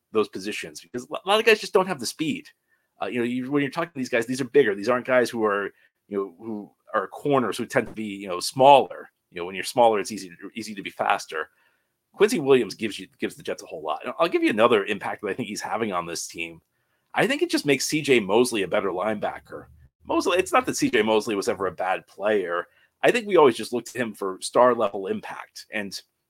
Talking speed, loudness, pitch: 255 wpm, -24 LUFS, 120 Hz